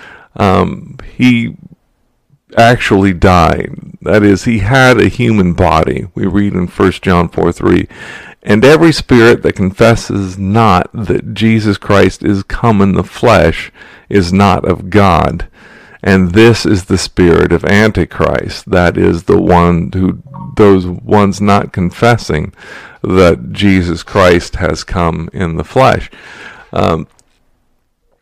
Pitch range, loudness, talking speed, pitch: 90-110 Hz, -10 LUFS, 130 wpm, 100 Hz